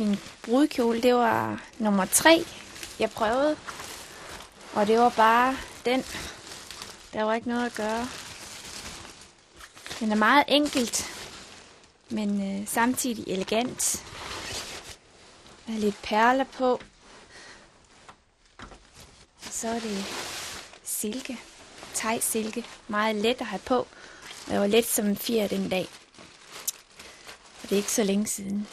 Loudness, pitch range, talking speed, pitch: -26 LUFS, 210-250 Hz, 125 wpm, 225 Hz